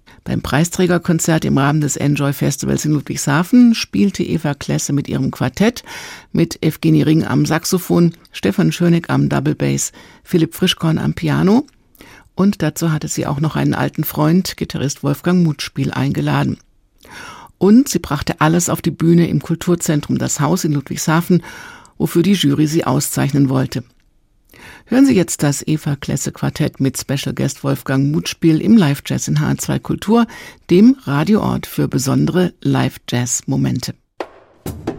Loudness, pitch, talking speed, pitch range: -16 LUFS, 160 Hz, 140 wpm, 140-175 Hz